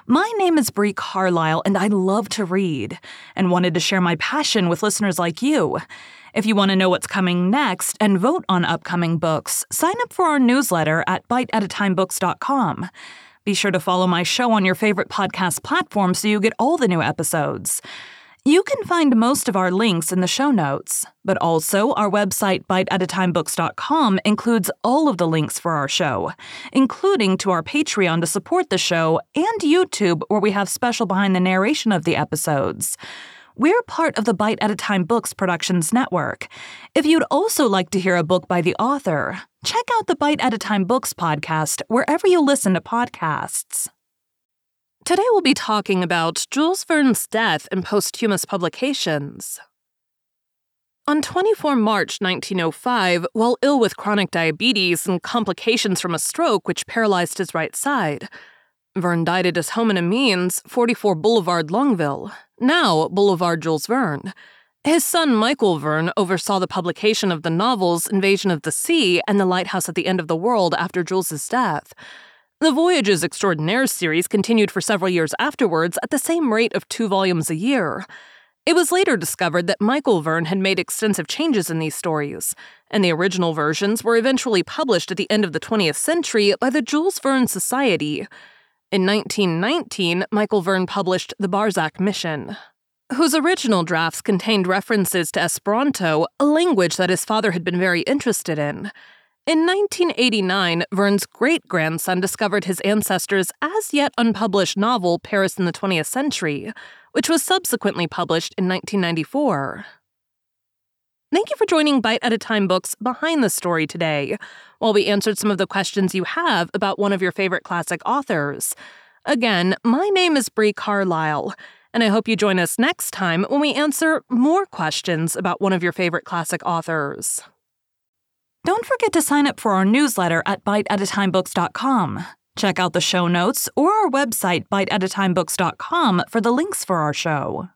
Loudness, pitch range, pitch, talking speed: -19 LUFS, 180-255 Hz, 200 Hz, 165 wpm